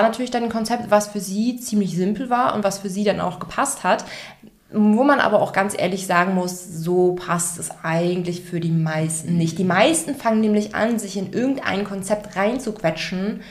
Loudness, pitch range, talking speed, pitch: -21 LUFS, 180-220 Hz, 195 wpm, 200 Hz